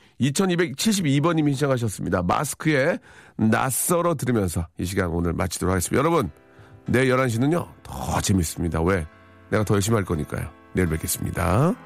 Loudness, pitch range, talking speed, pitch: -23 LUFS, 90-130 Hz, 345 characters per minute, 105 Hz